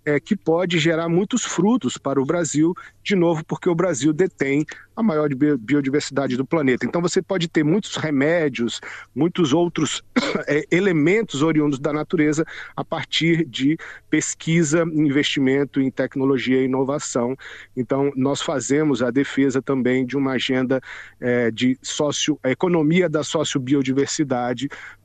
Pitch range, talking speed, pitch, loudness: 135-165 Hz, 135 wpm, 150 Hz, -21 LUFS